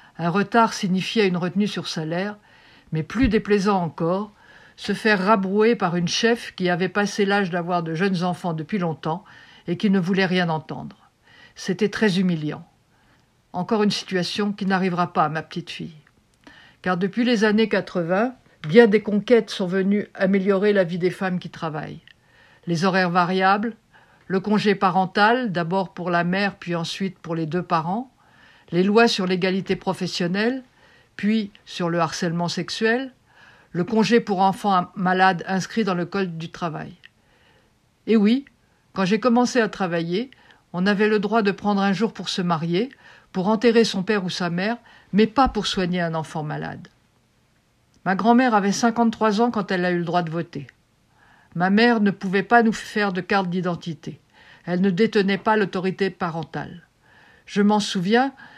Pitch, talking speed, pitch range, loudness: 195 Hz, 170 wpm, 175-215 Hz, -22 LUFS